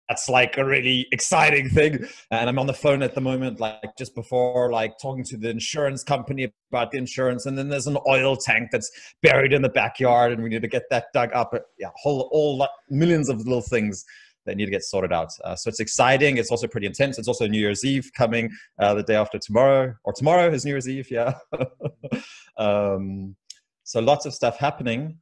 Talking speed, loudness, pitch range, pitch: 215 wpm, -22 LUFS, 115-140 Hz, 130 Hz